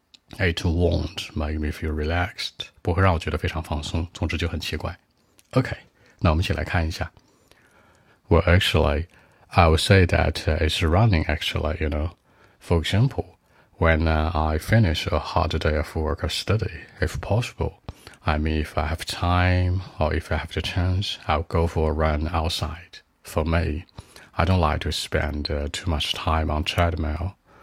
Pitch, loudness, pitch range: 85 Hz, -24 LUFS, 80-95 Hz